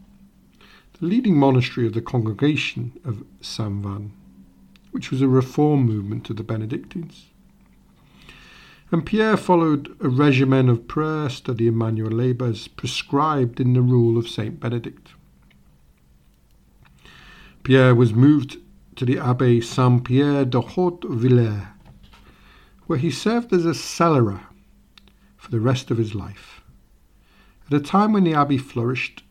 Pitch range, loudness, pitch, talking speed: 110-150 Hz, -20 LUFS, 125 Hz, 130 wpm